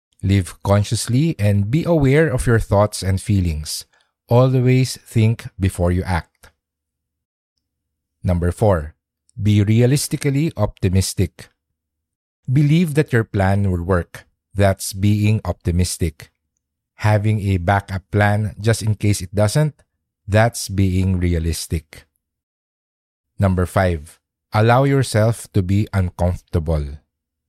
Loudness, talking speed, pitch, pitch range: -18 LUFS, 105 wpm, 95 Hz, 85-110 Hz